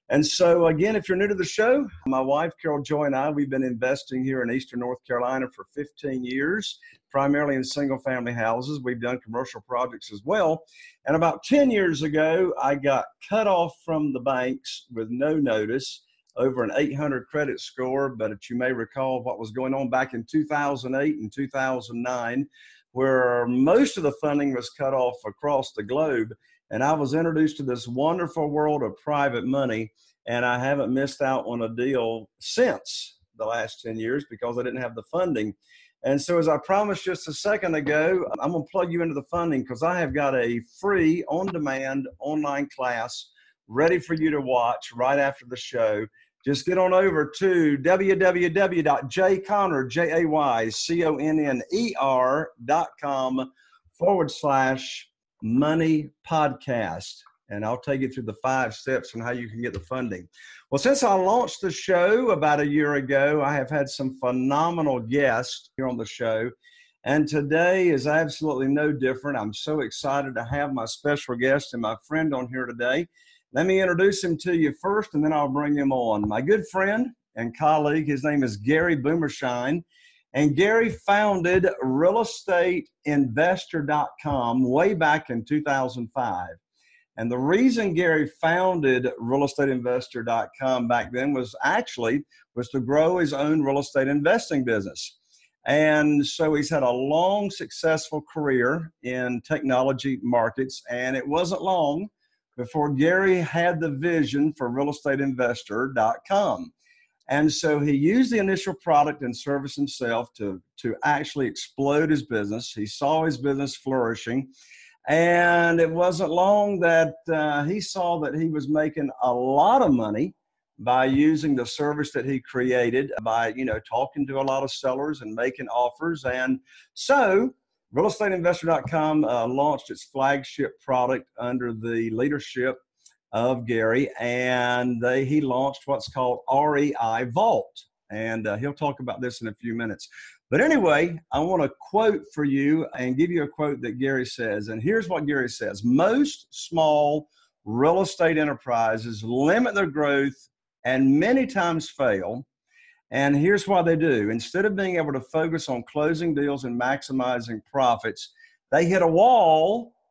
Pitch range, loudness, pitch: 125-165 Hz, -24 LUFS, 145 Hz